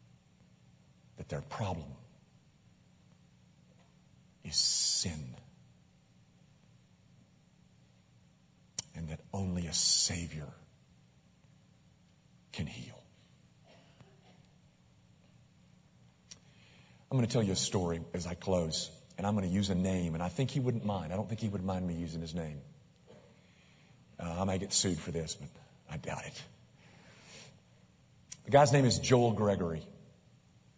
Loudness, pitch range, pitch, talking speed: -33 LUFS, 80-105 Hz, 90 Hz, 120 wpm